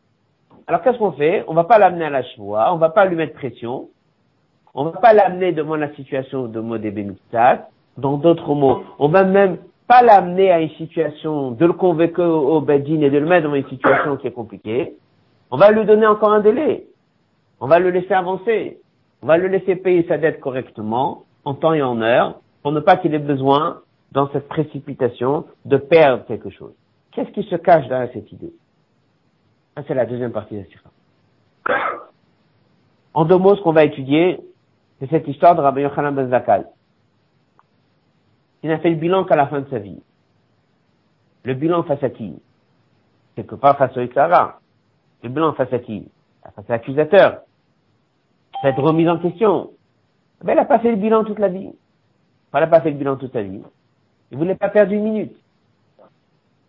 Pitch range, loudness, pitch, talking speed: 135-180 Hz, -17 LUFS, 155 Hz, 195 wpm